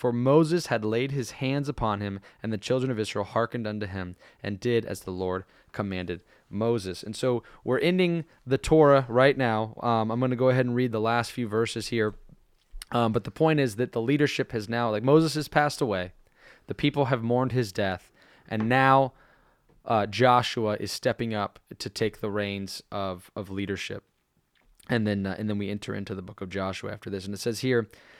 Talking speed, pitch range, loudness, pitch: 205 wpm, 100-130 Hz, -27 LUFS, 115 Hz